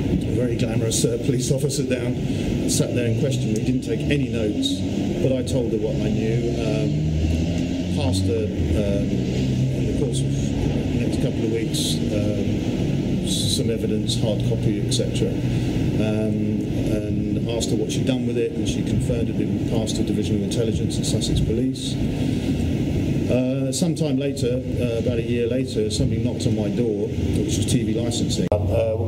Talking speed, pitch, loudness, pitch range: 170 wpm, 115 Hz, -22 LUFS, 105-130 Hz